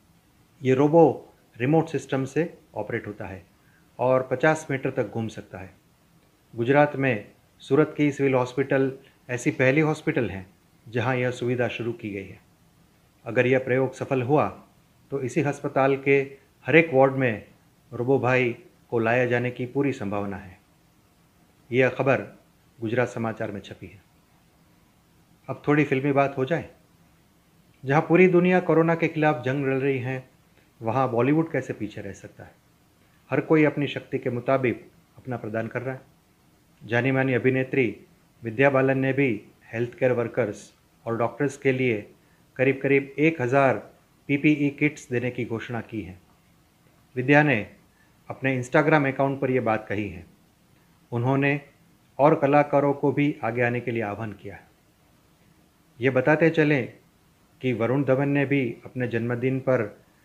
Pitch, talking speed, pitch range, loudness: 130 Hz, 150 wpm, 115-145 Hz, -24 LUFS